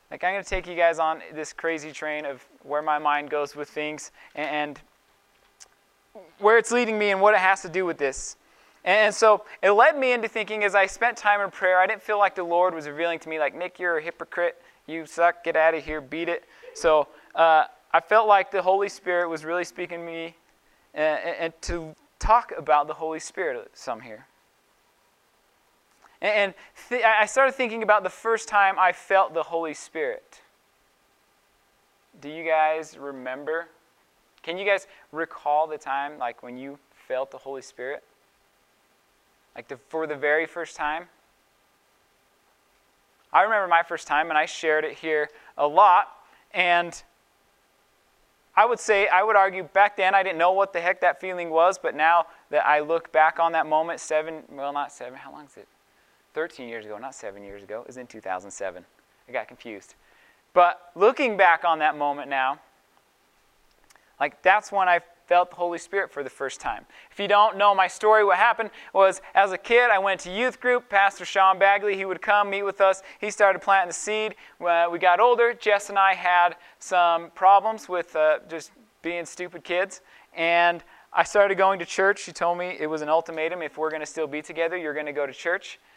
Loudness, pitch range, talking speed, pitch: -23 LUFS, 155-195 Hz, 195 wpm, 175 Hz